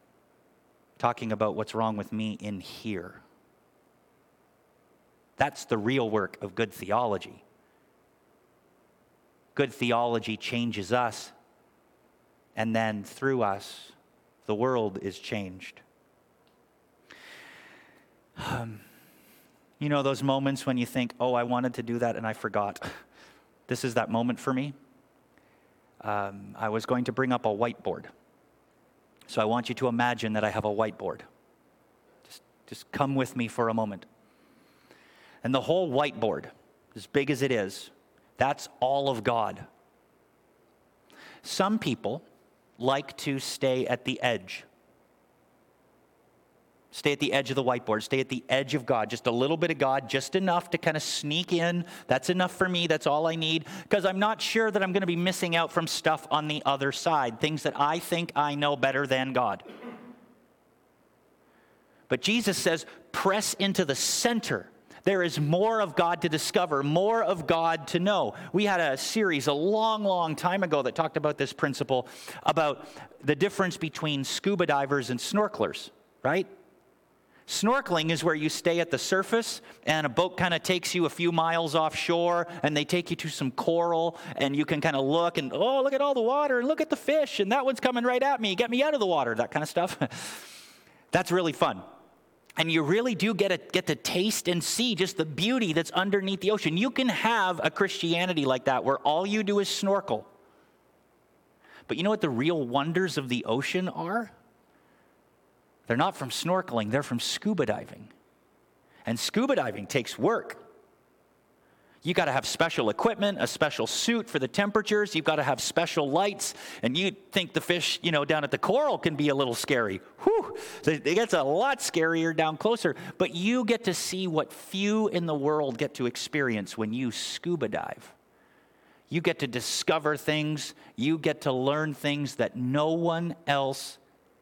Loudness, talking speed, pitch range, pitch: -28 LUFS, 175 wpm, 130-185 Hz, 160 Hz